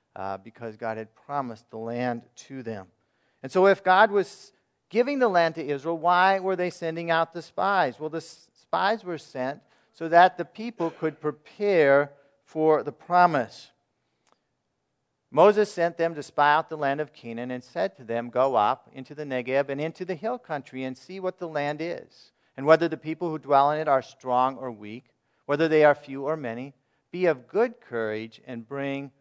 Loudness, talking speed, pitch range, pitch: -25 LUFS, 195 wpm, 130-170 Hz, 150 Hz